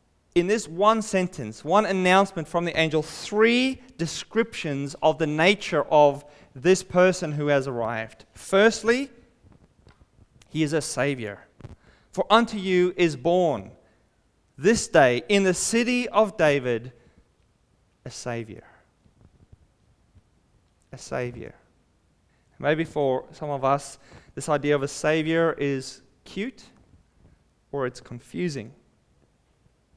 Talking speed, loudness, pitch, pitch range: 110 wpm, -23 LUFS, 155 Hz, 130-190 Hz